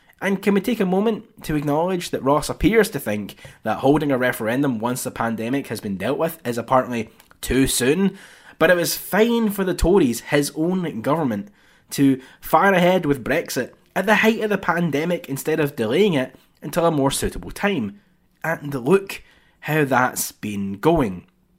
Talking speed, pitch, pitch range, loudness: 180 wpm, 150 Hz, 130-185 Hz, -21 LUFS